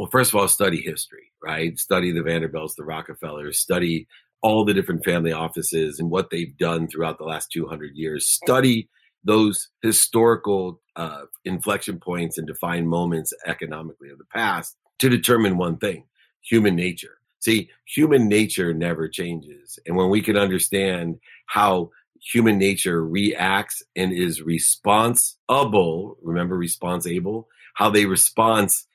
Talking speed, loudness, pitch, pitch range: 140 wpm, -21 LUFS, 90 Hz, 80-105 Hz